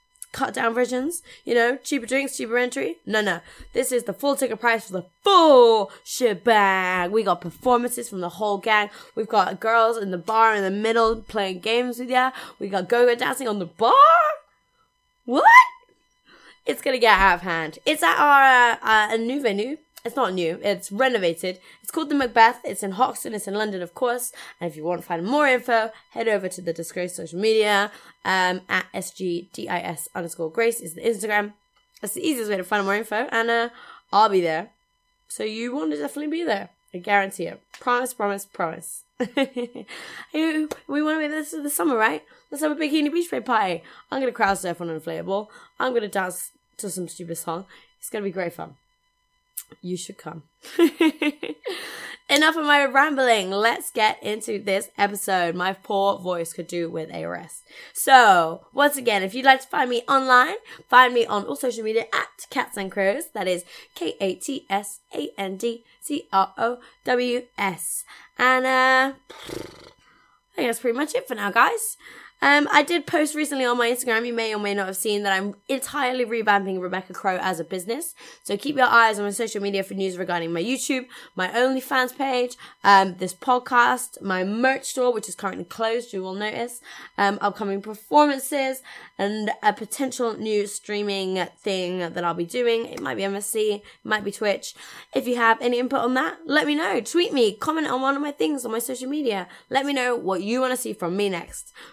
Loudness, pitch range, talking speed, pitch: -22 LUFS, 195-265 Hz, 200 wpm, 225 Hz